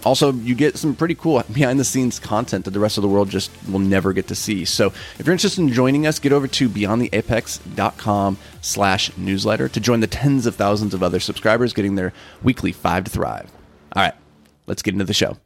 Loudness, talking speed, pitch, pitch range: -19 LUFS, 215 wpm, 105 Hz, 95-130 Hz